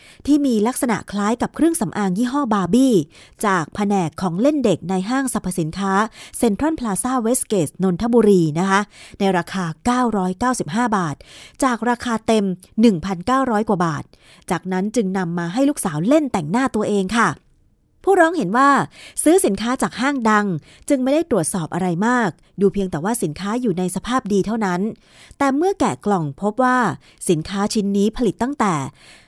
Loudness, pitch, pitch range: -19 LUFS, 210 Hz, 190-250 Hz